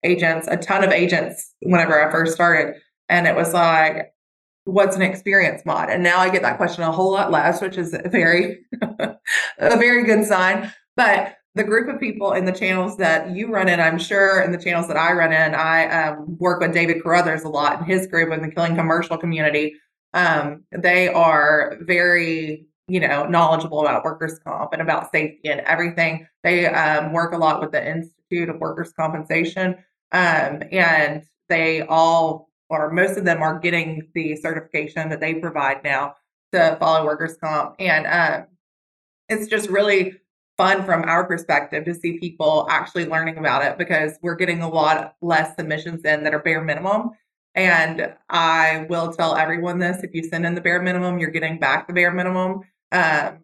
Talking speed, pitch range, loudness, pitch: 185 wpm, 160-180 Hz, -19 LUFS, 170 Hz